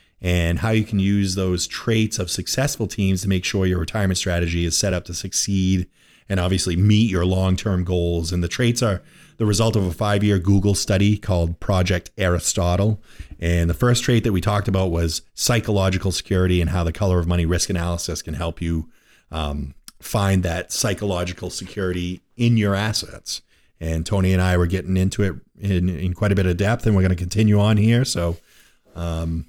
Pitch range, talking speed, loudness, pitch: 90-105 Hz, 195 wpm, -21 LUFS, 95 Hz